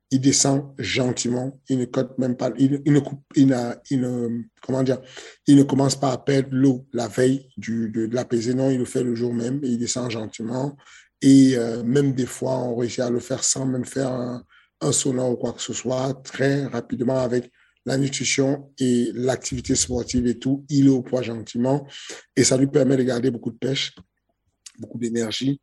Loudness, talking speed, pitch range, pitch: -22 LUFS, 185 wpm, 120-135 Hz, 130 Hz